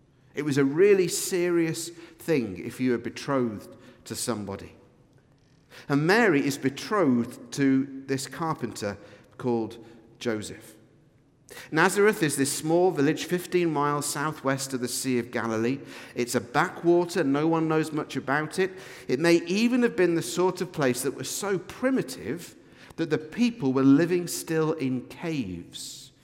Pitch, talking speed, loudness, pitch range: 140 Hz, 145 wpm, -26 LUFS, 125-165 Hz